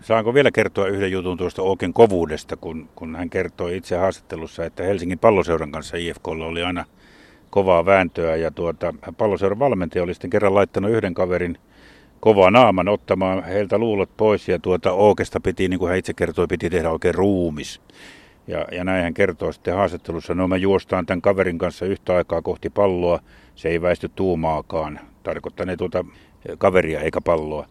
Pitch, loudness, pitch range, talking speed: 90 Hz, -20 LUFS, 85-95 Hz, 170 wpm